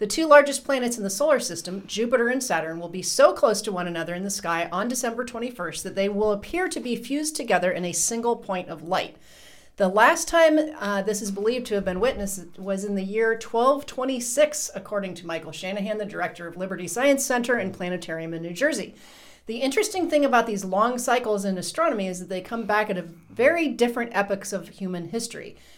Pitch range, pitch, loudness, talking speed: 185-255 Hz, 210 Hz, -24 LUFS, 210 wpm